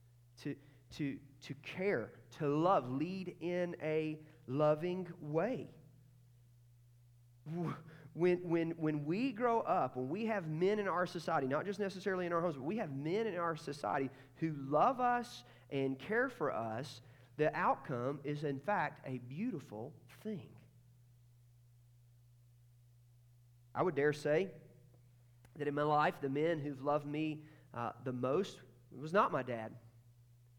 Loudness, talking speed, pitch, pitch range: -37 LUFS, 145 wpm, 140 Hz, 120-165 Hz